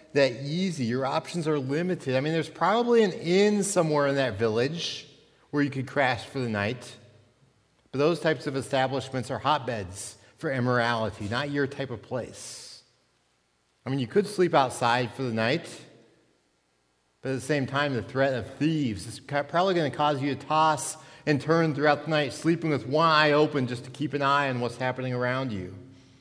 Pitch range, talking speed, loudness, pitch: 120-150 Hz, 190 wpm, -26 LUFS, 135 Hz